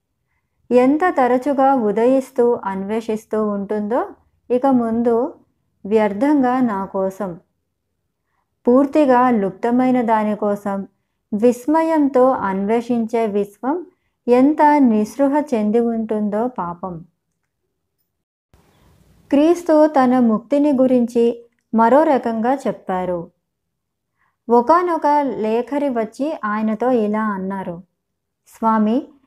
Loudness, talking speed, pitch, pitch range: -17 LUFS, 70 wpm, 235 Hz, 210-270 Hz